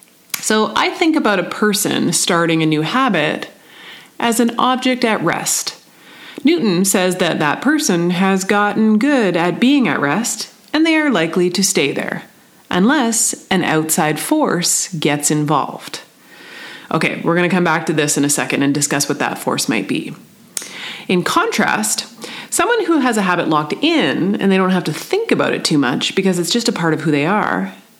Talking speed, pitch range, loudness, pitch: 185 wpm, 165-250 Hz, -16 LUFS, 195 Hz